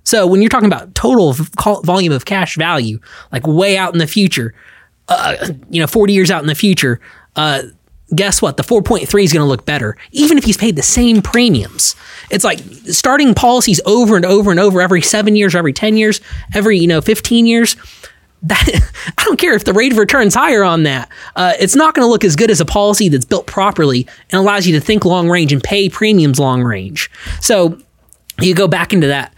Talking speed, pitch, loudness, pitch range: 225 wpm, 195 Hz, -12 LUFS, 155-215 Hz